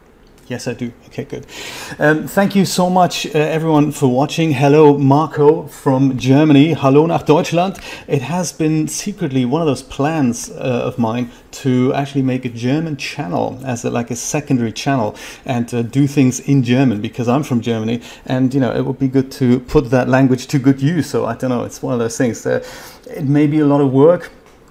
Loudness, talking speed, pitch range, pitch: -16 LUFS, 205 wpm, 125-150 Hz, 135 Hz